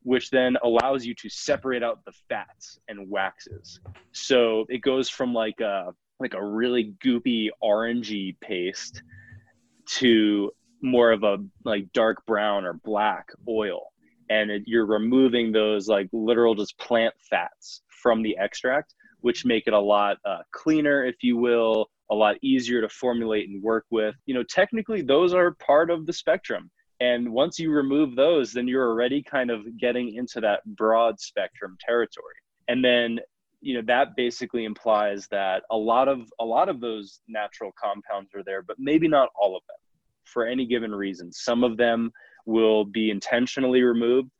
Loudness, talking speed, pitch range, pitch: -24 LUFS, 170 wpm, 110-125 Hz, 115 Hz